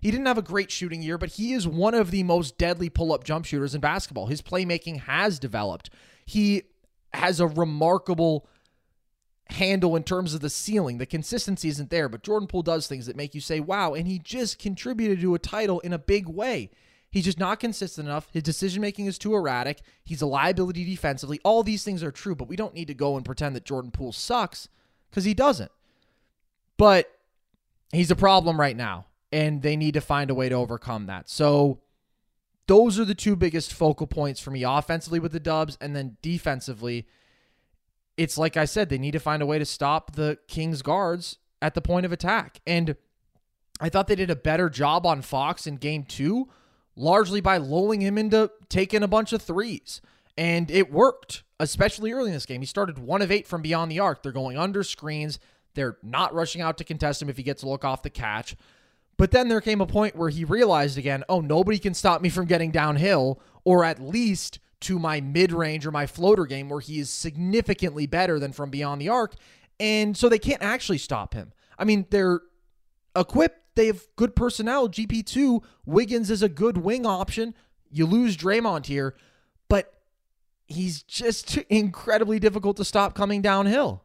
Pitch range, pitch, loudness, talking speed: 150-205 Hz, 170 Hz, -25 LUFS, 200 wpm